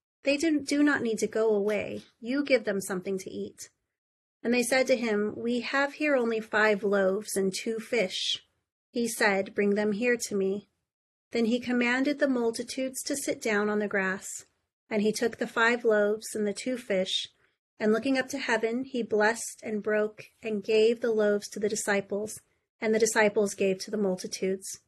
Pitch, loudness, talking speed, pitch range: 220 Hz, -28 LUFS, 190 wpm, 205-245 Hz